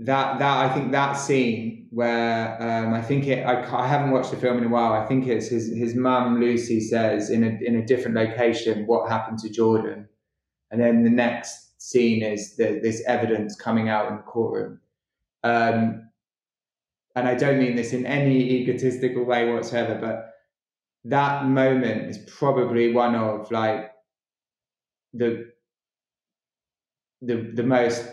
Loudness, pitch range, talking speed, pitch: -23 LUFS, 115-125 Hz, 160 wpm, 120 Hz